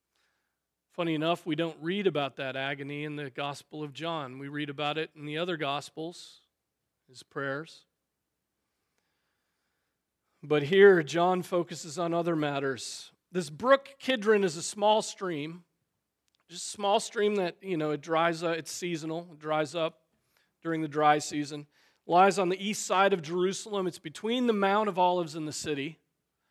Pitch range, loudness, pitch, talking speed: 150-185 Hz, -29 LUFS, 165 Hz, 165 wpm